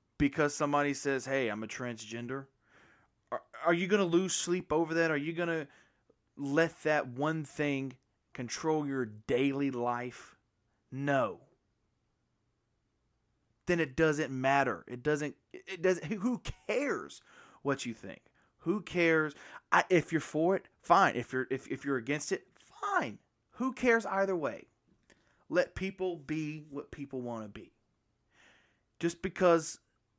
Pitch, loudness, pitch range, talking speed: 145 Hz, -32 LUFS, 125-165 Hz, 140 wpm